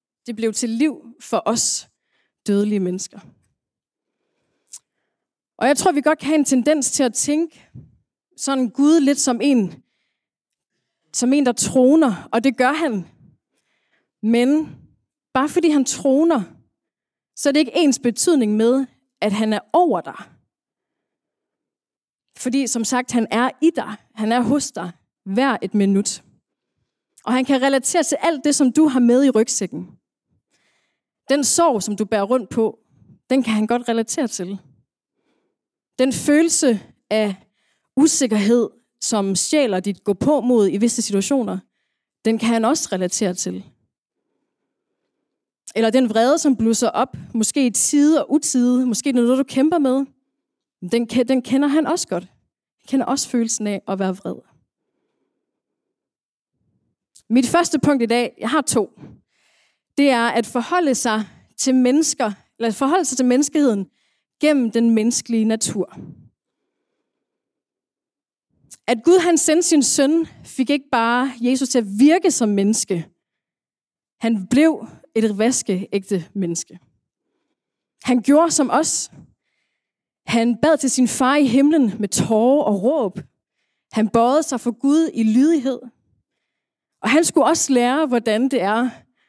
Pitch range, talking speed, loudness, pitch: 220-285 Hz, 145 wpm, -18 LUFS, 250 Hz